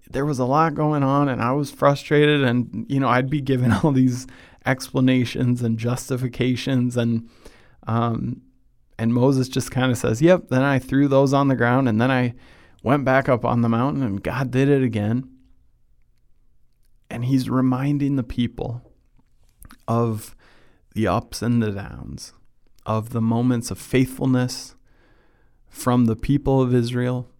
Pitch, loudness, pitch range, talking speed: 125 Hz, -21 LUFS, 115-135 Hz, 160 wpm